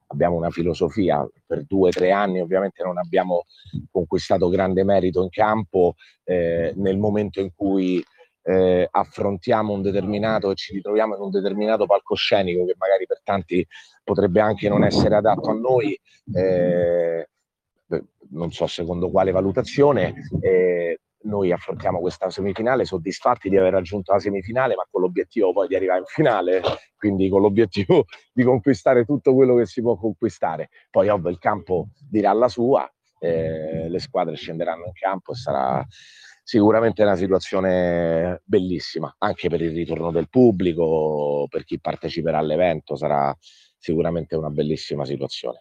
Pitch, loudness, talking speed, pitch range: 95 Hz, -21 LUFS, 145 wpm, 90-105 Hz